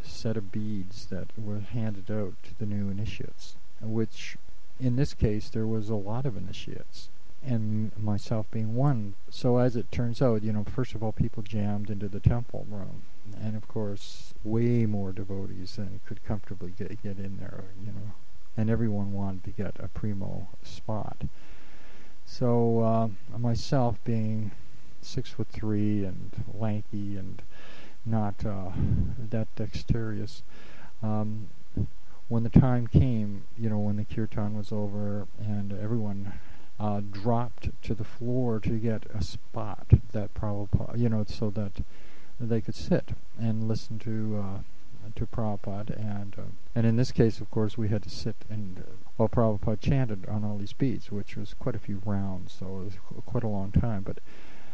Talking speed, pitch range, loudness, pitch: 165 wpm, 100-115 Hz, -31 LUFS, 105 Hz